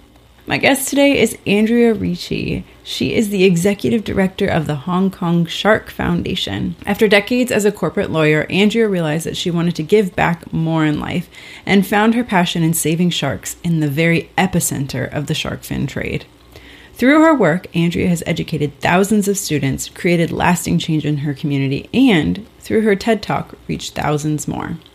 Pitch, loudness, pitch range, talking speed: 170 Hz, -16 LUFS, 150-205 Hz, 175 wpm